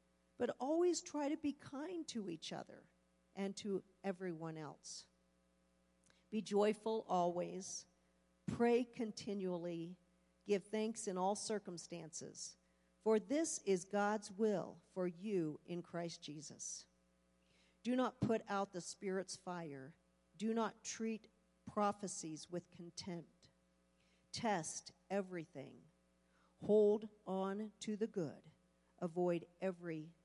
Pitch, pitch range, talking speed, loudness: 180 Hz, 145-210 Hz, 110 wpm, -42 LUFS